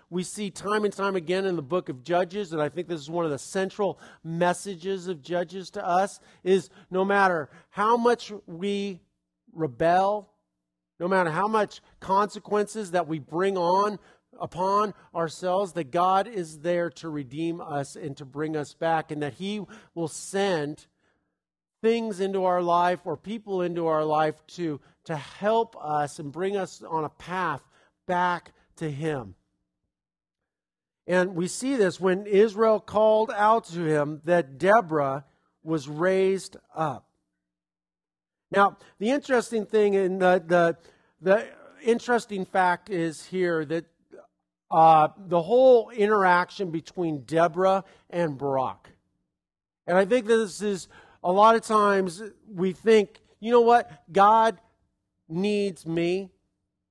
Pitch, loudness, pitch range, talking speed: 180 Hz, -25 LUFS, 160-200 Hz, 145 wpm